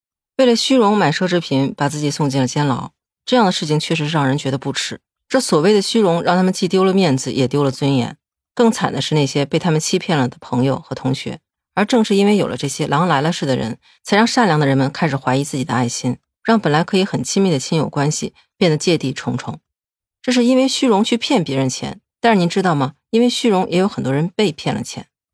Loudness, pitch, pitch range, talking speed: -17 LUFS, 160 Hz, 135-200 Hz, 345 characters per minute